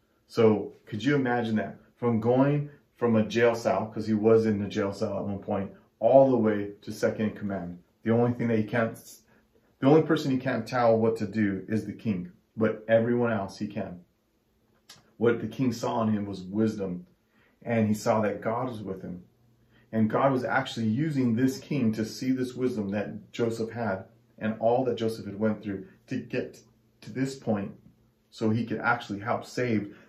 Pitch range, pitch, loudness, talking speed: 105-120 Hz, 115 Hz, -28 LUFS, 195 wpm